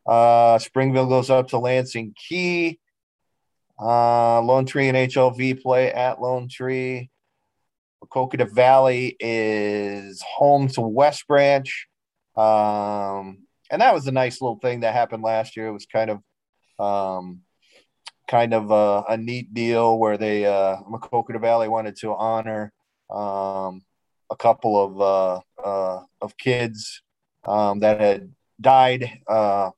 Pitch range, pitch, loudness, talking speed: 105-130 Hz, 115 Hz, -21 LUFS, 135 wpm